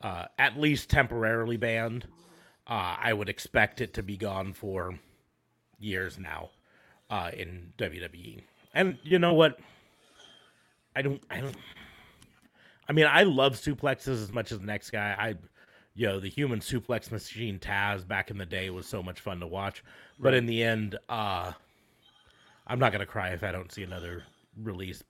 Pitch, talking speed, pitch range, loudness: 110 Hz, 170 wpm, 95-125 Hz, -29 LUFS